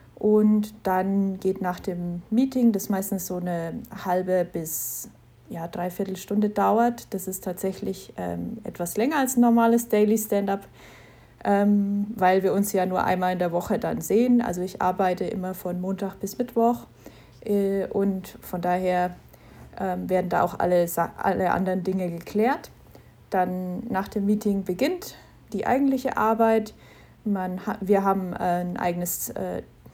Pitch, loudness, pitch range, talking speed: 195 Hz, -25 LUFS, 180-210 Hz, 150 wpm